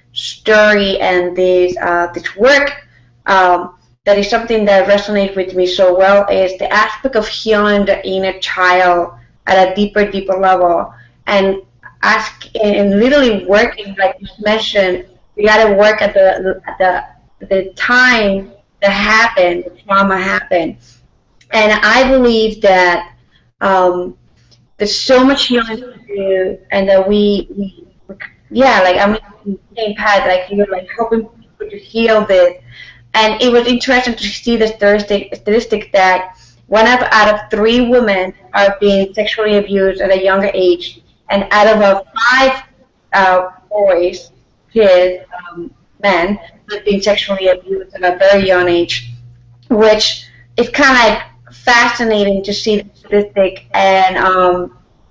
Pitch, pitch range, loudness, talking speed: 200 Hz, 185-215 Hz, -12 LUFS, 145 wpm